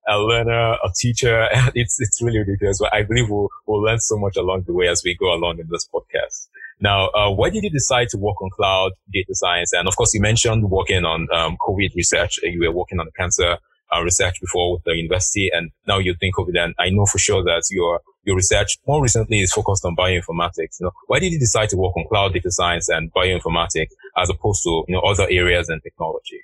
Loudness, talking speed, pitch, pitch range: -19 LUFS, 230 wpm, 100 Hz, 90-115 Hz